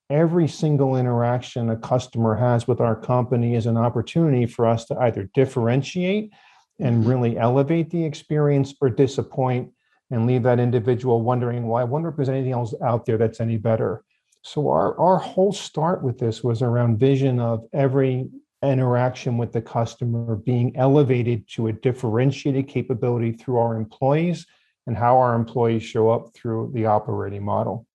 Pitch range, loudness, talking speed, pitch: 115-135 Hz, -22 LUFS, 165 wpm, 125 Hz